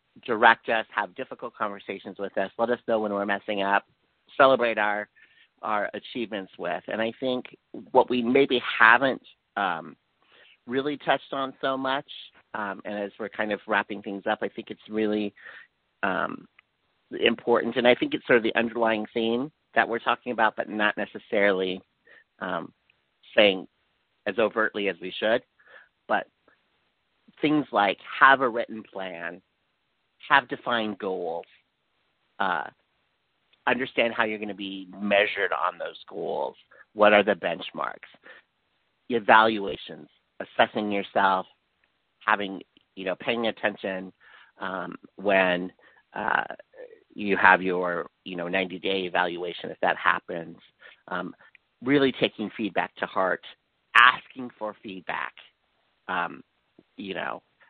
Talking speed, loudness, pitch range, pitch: 135 wpm, -25 LUFS, 100-120 Hz, 105 Hz